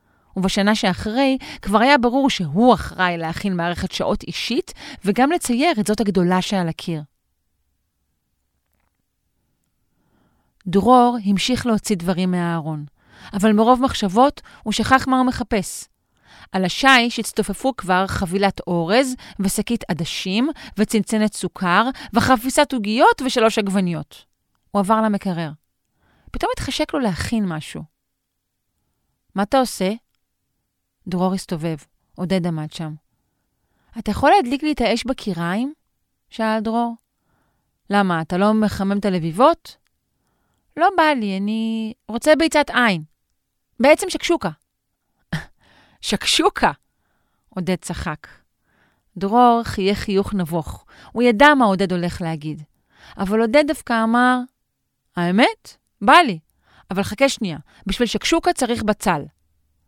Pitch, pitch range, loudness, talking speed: 205 Hz, 175-245 Hz, -19 LUFS, 110 wpm